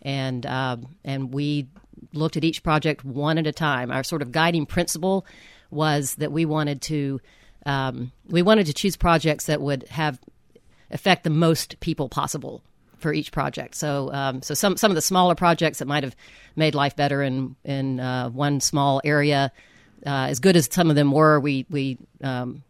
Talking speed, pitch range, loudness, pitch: 190 wpm, 135-160 Hz, -23 LUFS, 145 Hz